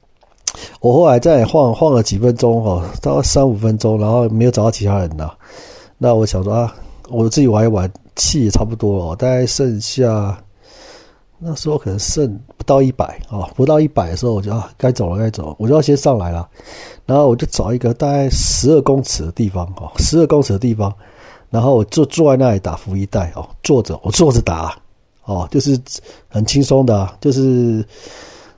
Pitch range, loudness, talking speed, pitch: 100-135 Hz, -15 LUFS, 275 characters per minute, 115 Hz